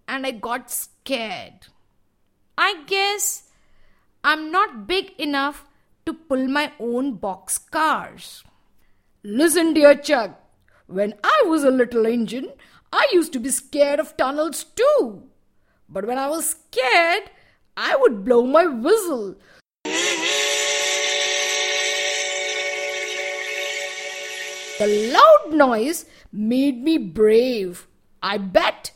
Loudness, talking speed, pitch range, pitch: -20 LUFS, 105 wpm, 190-310 Hz, 255 Hz